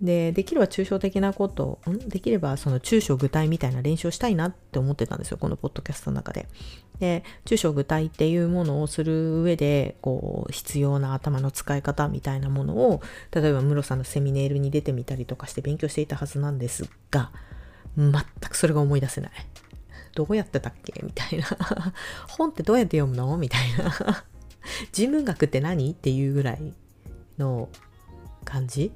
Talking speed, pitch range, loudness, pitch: 370 characters per minute, 135-175 Hz, -26 LUFS, 145 Hz